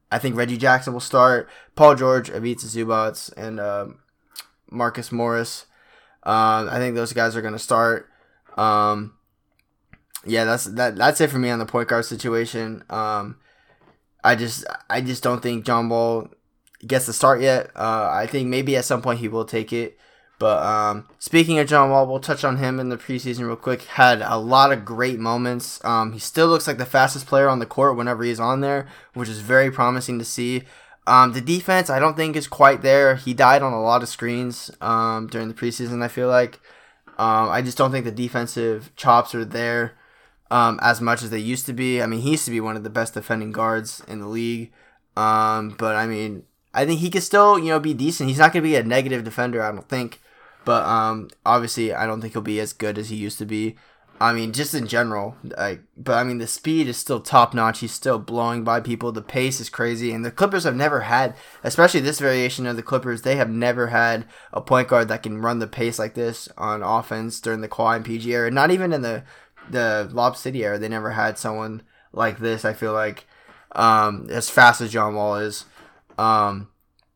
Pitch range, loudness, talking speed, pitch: 110-130 Hz, -20 LUFS, 220 wpm, 120 Hz